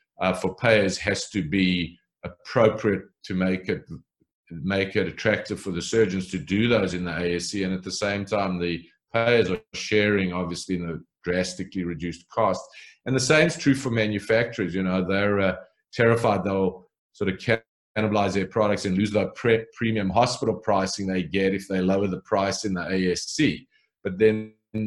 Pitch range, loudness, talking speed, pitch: 90-110 Hz, -24 LUFS, 180 wpm, 95 Hz